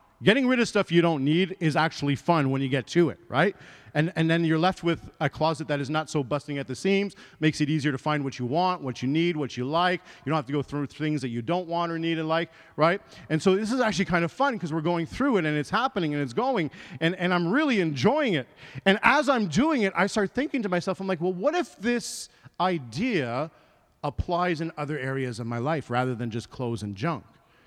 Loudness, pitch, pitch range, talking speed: -26 LUFS, 165 Hz, 145-190 Hz, 255 wpm